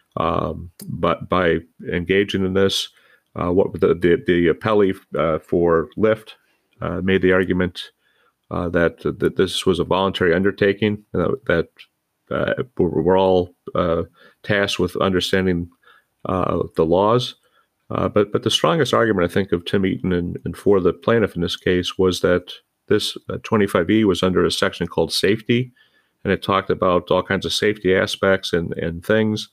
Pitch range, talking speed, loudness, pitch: 90-100 Hz, 170 wpm, -20 LUFS, 95 Hz